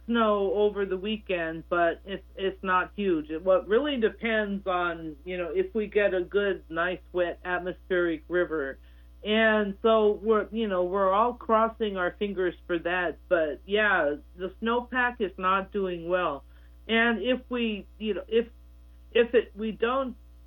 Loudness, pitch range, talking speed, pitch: -27 LUFS, 175-220 Hz, 165 wpm, 195 Hz